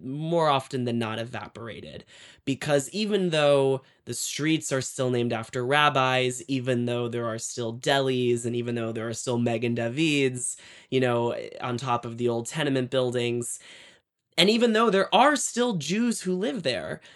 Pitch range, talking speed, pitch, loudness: 120-150 Hz, 170 wpm, 130 Hz, -25 LUFS